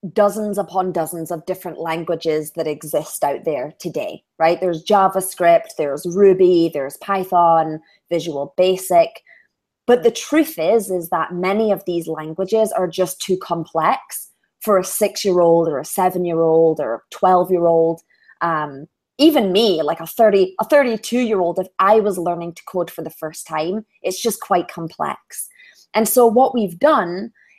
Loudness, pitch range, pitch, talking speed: -18 LUFS, 165-205 Hz, 185 Hz, 170 wpm